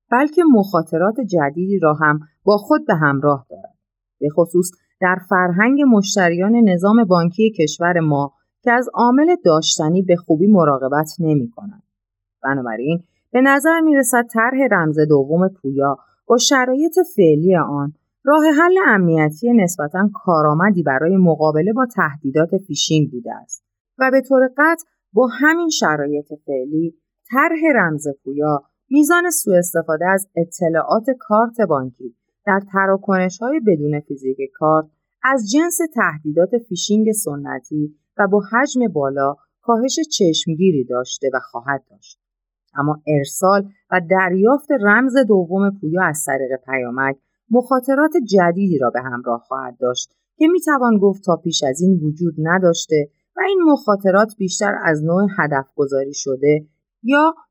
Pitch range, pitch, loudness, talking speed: 150-230 Hz, 180 Hz, -17 LUFS, 135 wpm